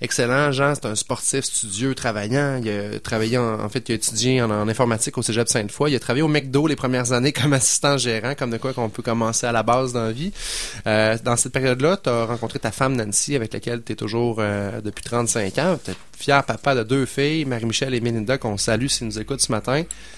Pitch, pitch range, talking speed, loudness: 120 Hz, 110-135 Hz, 240 wpm, -21 LUFS